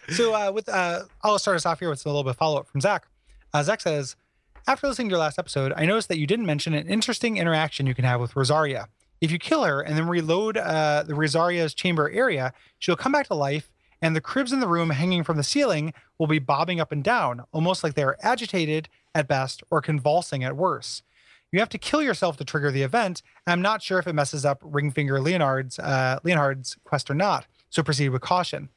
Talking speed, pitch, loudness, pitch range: 235 wpm, 155 Hz, -24 LUFS, 145-180 Hz